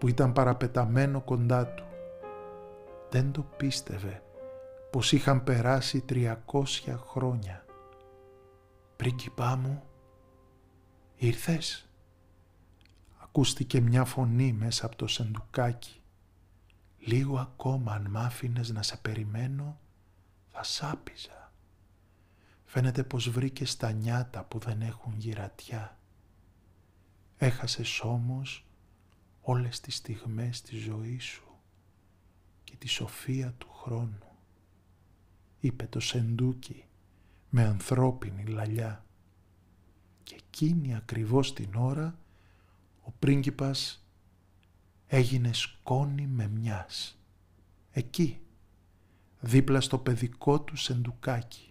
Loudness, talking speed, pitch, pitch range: -31 LUFS, 90 wpm, 115 Hz, 95-130 Hz